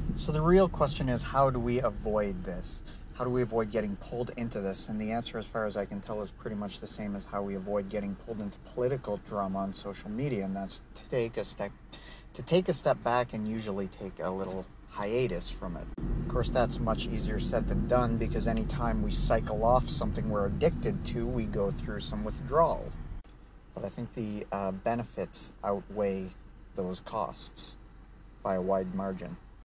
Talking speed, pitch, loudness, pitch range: 200 wpm, 105 Hz, -32 LUFS, 95-120 Hz